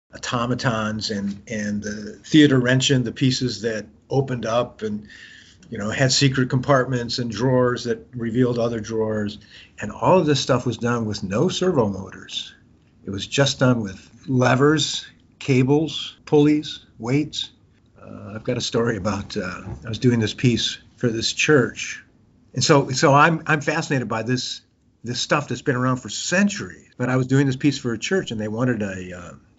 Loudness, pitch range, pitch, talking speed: -21 LUFS, 110-135 Hz, 120 Hz, 175 wpm